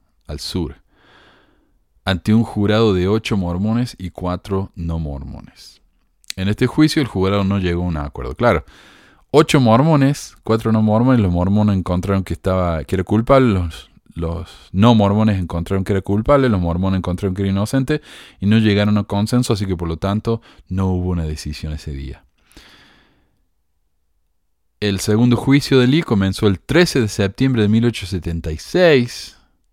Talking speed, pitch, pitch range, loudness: 155 wpm, 100 Hz, 90-115 Hz, -17 LUFS